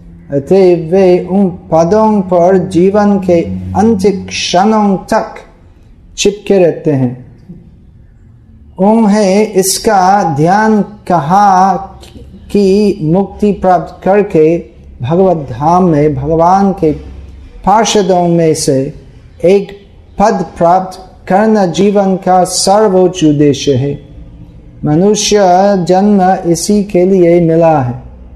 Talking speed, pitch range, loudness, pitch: 95 wpm, 150-200 Hz, -9 LUFS, 180 Hz